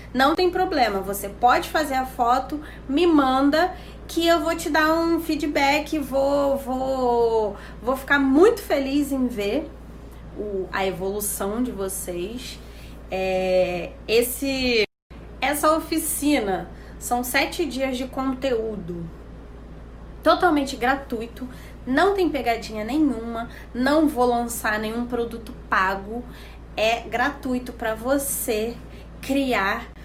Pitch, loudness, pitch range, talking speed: 255 Hz, -23 LUFS, 220-285 Hz, 110 wpm